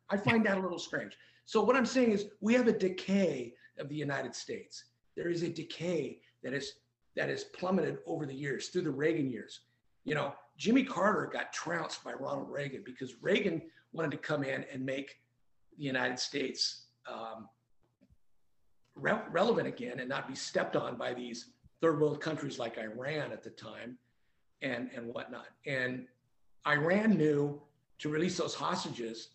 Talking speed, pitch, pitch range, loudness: 170 wpm, 145 Hz, 125-170 Hz, -34 LUFS